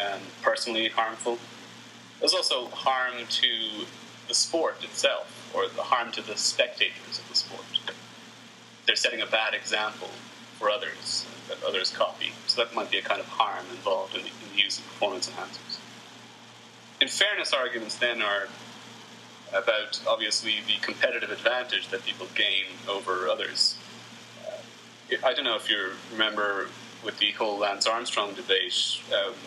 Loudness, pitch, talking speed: -27 LUFS, 125 Hz, 155 wpm